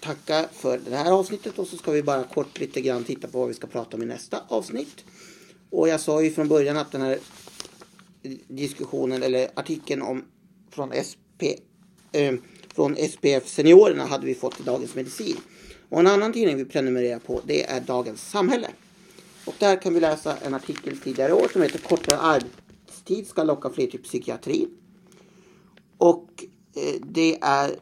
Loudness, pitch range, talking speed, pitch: -24 LUFS, 135-195 Hz, 175 wpm, 160 Hz